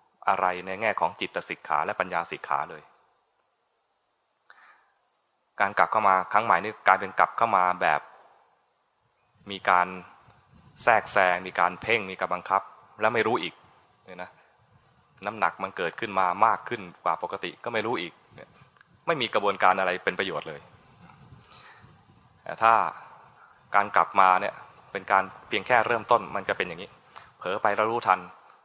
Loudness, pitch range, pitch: -25 LUFS, 90-100 Hz, 95 Hz